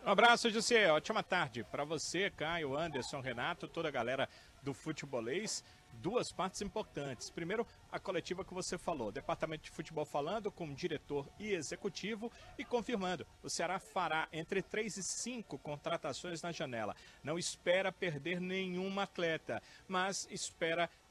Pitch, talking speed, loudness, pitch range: 180 Hz, 150 wpm, -38 LUFS, 160-200 Hz